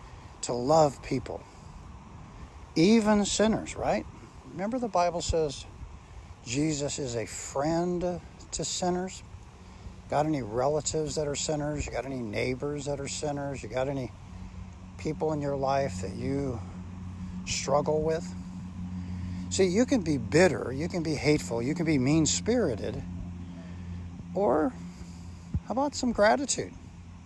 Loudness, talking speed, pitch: -29 LUFS, 130 wpm, 130 Hz